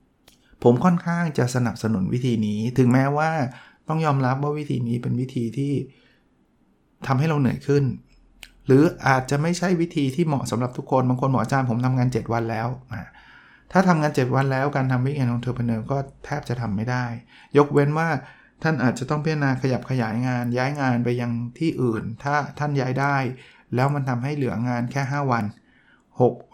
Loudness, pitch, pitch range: -23 LUFS, 130 Hz, 120-145 Hz